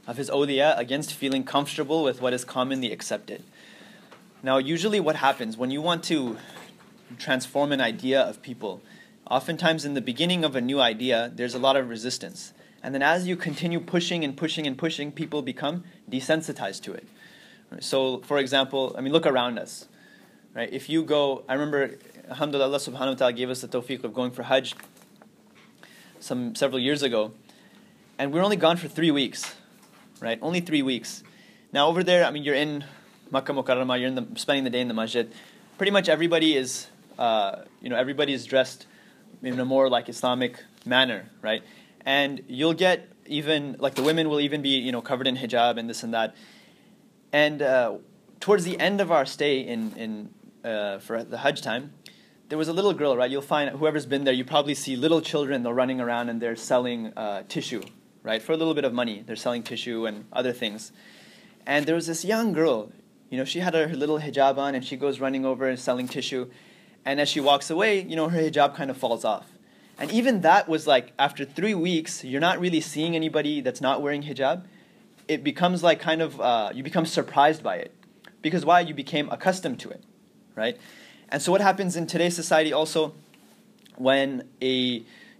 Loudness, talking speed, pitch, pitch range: -25 LUFS, 195 wpm, 145 Hz, 130-165 Hz